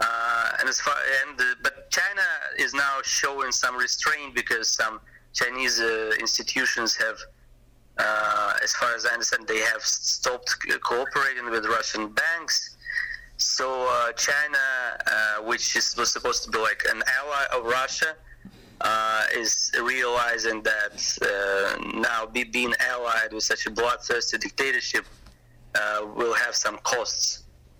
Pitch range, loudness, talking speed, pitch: 105-125 Hz, -24 LUFS, 140 wpm, 115 Hz